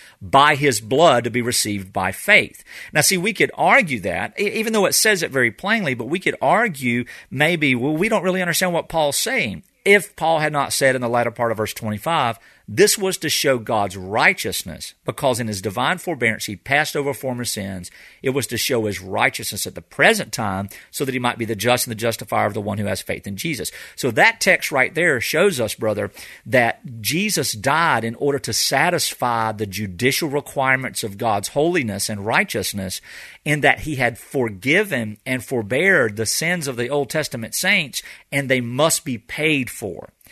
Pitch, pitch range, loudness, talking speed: 125 Hz, 110-150 Hz, -19 LUFS, 200 wpm